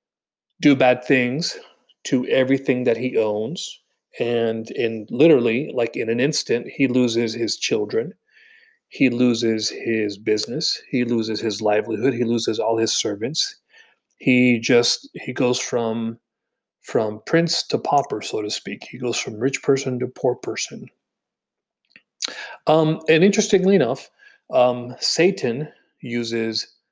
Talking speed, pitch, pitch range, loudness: 130 wpm, 125 Hz, 115-155 Hz, -21 LUFS